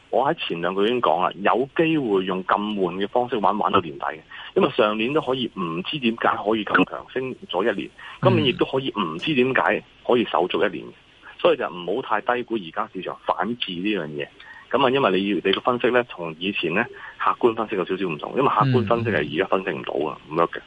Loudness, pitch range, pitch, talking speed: -23 LUFS, 95-125 Hz, 110 Hz, 345 characters per minute